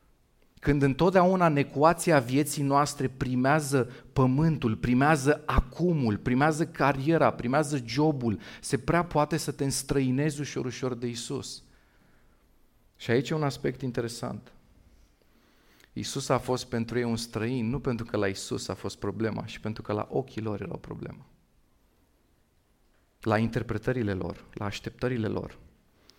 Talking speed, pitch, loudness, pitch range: 135 wpm, 130 Hz, -28 LUFS, 110-145 Hz